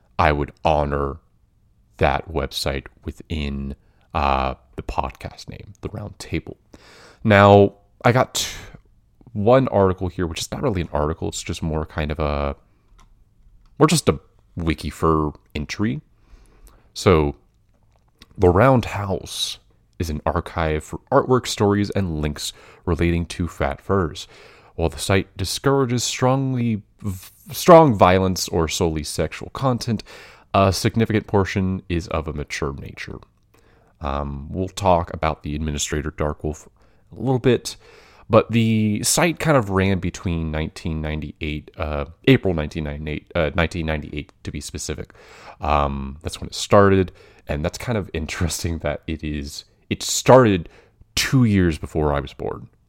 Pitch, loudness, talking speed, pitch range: 90 Hz, -21 LUFS, 135 wpm, 75-105 Hz